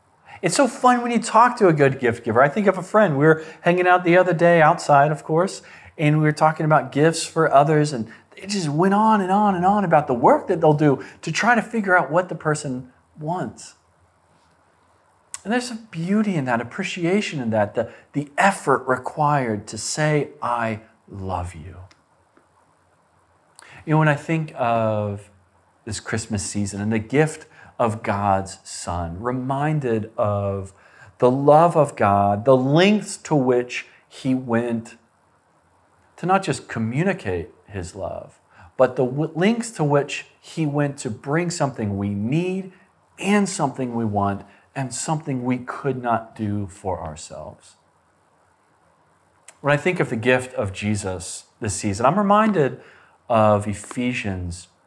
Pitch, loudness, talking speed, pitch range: 135 Hz, -21 LUFS, 160 wpm, 105-165 Hz